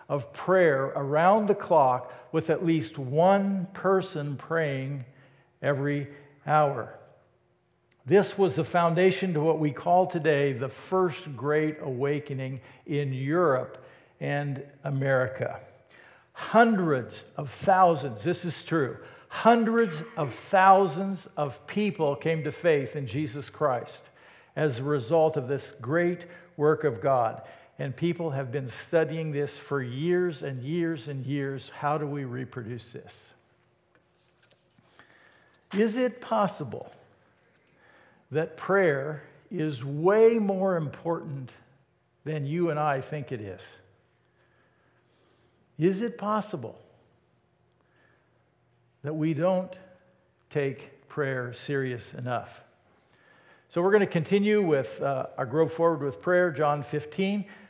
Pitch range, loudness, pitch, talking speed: 140-180 Hz, -27 LUFS, 150 Hz, 120 wpm